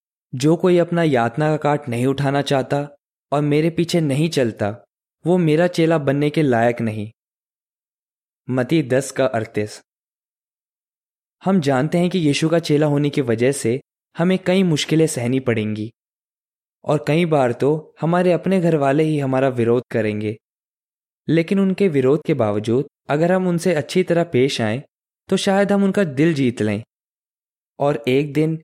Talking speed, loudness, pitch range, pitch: 155 wpm, -19 LUFS, 125-165 Hz, 145 Hz